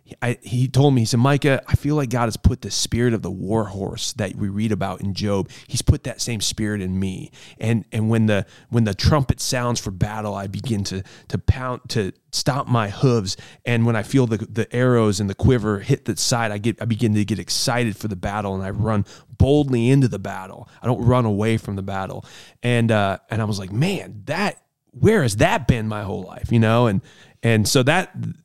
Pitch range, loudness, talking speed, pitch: 105-125 Hz, -21 LUFS, 230 wpm, 115 Hz